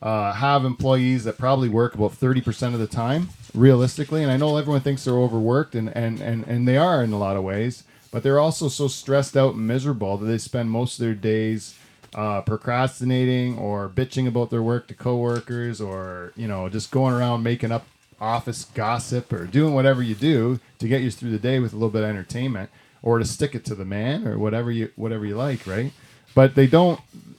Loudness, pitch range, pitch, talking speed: -22 LUFS, 110-135 Hz, 120 Hz, 215 wpm